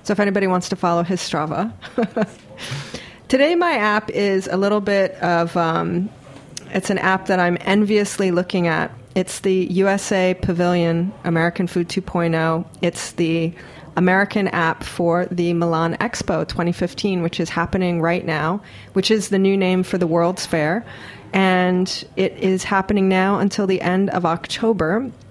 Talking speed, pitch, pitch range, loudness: 155 wpm, 185 Hz, 170-195 Hz, -19 LUFS